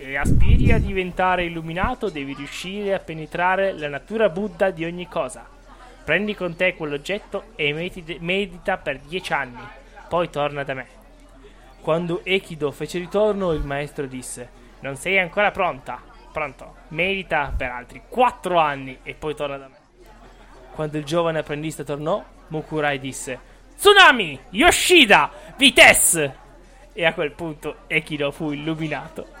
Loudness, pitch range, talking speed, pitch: -20 LUFS, 145-185 Hz, 140 wpm, 160 Hz